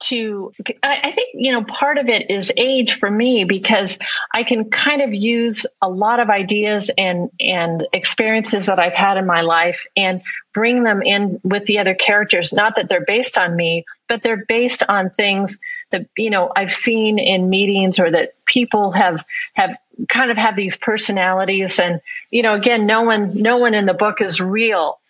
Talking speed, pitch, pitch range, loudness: 190 wpm, 210 Hz, 190-235 Hz, -16 LUFS